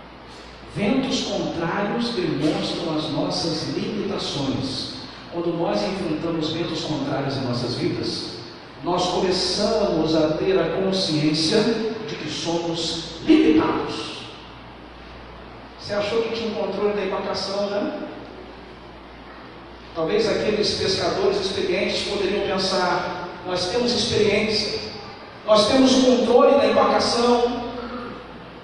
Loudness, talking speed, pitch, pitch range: -22 LUFS, 100 wpm, 195 Hz, 165-220 Hz